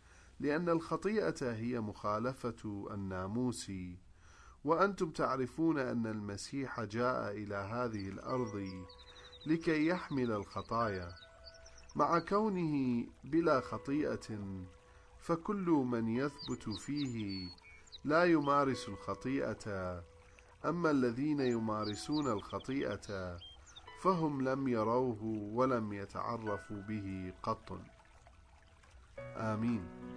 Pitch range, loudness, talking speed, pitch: 95-135 Hz, -36 LUFS, 80 wpm, 110 Hz